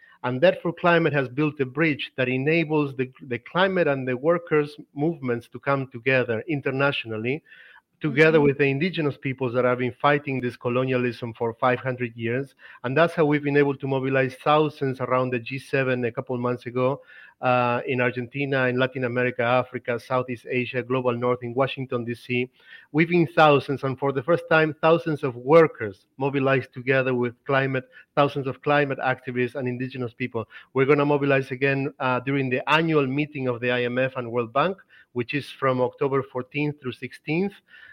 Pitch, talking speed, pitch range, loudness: 135 Hz, 175 wpm, 125-145 Hz, -24 LUFS